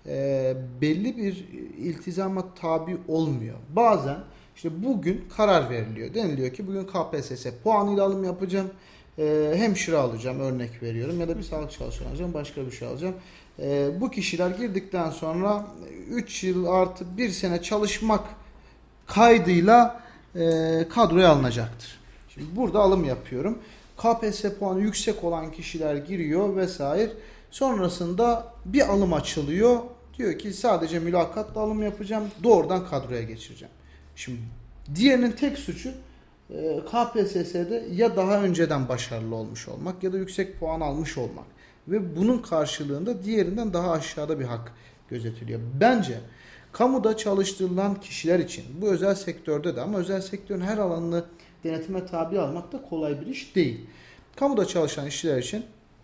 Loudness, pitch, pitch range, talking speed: -26 LUFS, 180 Hz, 150-205 Hz, 135 wpm